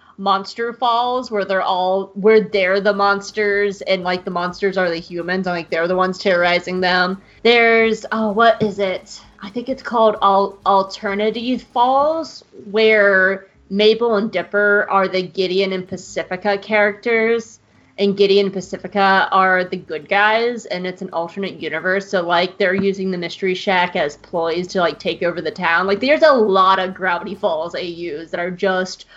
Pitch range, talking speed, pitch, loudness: 185-210 Hz, 175 wpm, 195 Hz, -17 LUFS